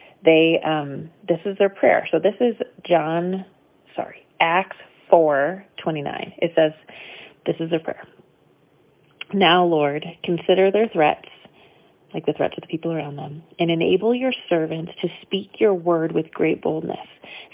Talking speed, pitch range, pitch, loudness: 155 wpm, 160-190 Hz, 170 Hz, -21 LUFS